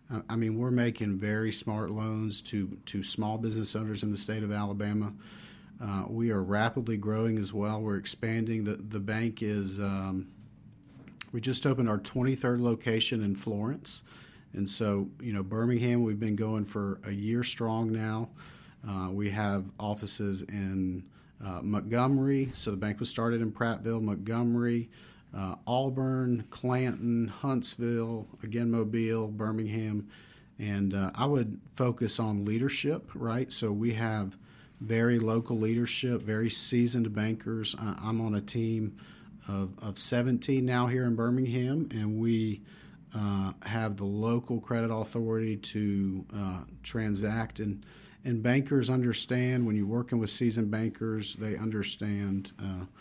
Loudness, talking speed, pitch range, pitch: -31 LUFS, 145 wpm, 105-120 Hz, 110 Hz